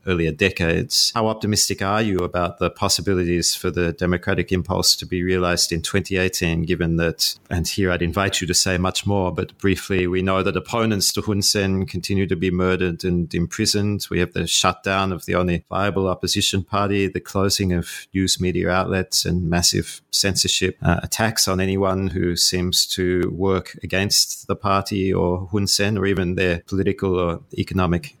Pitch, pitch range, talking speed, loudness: 95 Hz, 90-100 Hz, 175 wpm, -20 LUFS